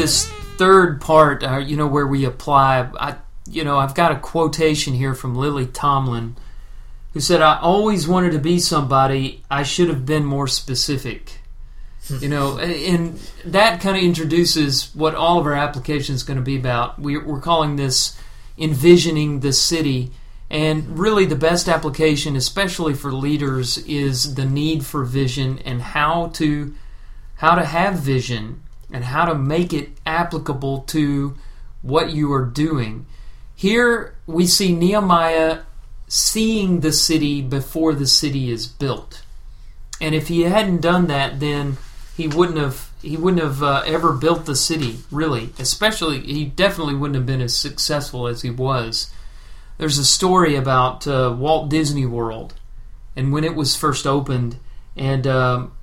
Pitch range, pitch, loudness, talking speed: 135-165 Hz, 145 Hz, -18 LUFS, 160 wpm